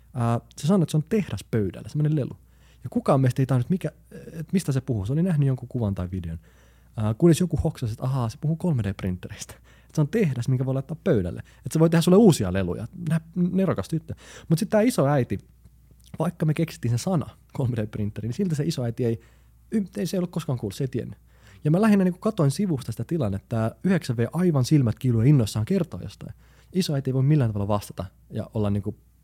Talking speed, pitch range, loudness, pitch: 215 wpm, 110-165 Hz, -25 LUFS, 135 Hz